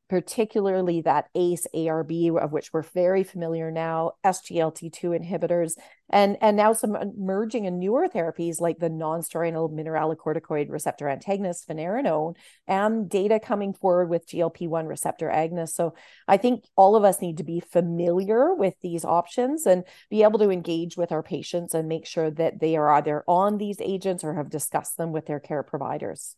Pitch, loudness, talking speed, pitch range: 170 Hz, -25 LUFS, 170 wpm, 160-190 Hz